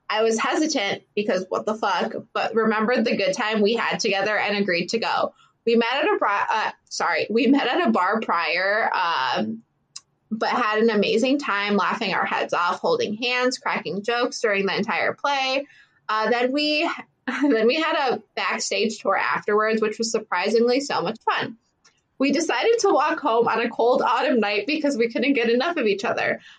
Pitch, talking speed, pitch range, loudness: 230 Hz, 190 wpm, 215-270 Hz, -22 LUFS